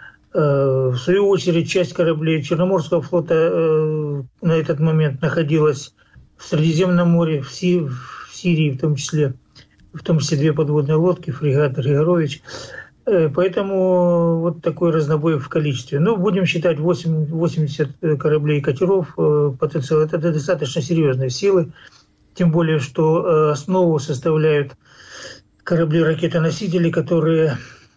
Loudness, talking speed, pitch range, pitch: -18 LUFS, 115 wpm, 150-170 Hz, 160 Hz